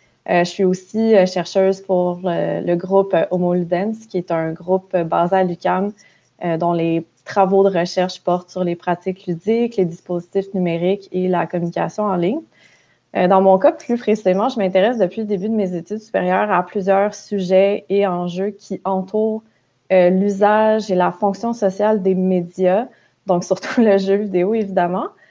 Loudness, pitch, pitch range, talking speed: -18 LUFS, 190 Hz, 180-205 Hz, 175 wpm